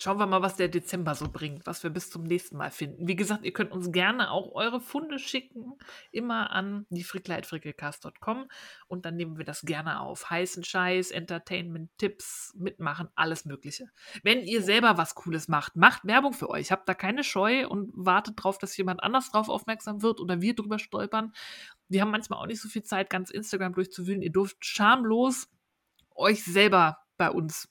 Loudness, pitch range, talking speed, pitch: -28 LUFS, 175-220 Hz, 190 wpm, 195 Hz